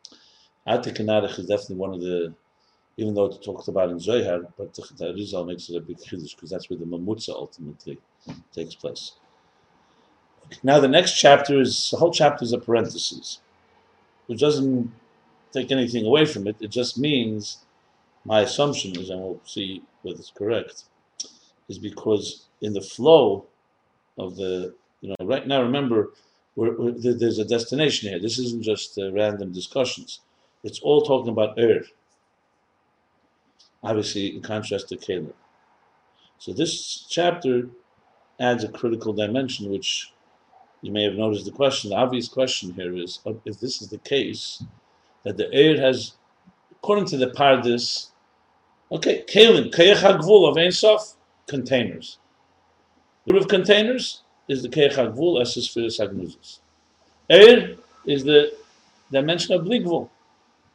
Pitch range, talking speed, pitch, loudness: 105-140 Hz, 150 wpm, 120 Hz, -21 LUFS